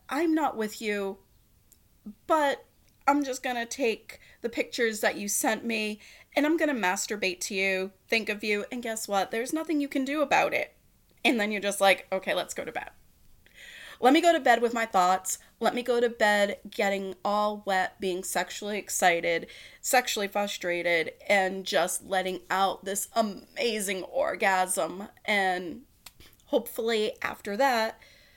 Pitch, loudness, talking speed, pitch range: 210 Hz, -27 LUFS, 160 wpm, 190-240 Hz